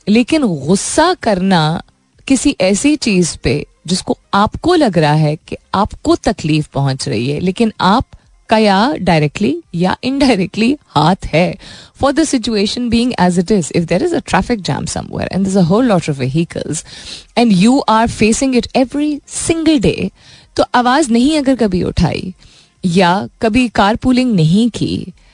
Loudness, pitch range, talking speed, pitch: -14 LUFS, 175-255 Hz, 160 wpm, 215 Hz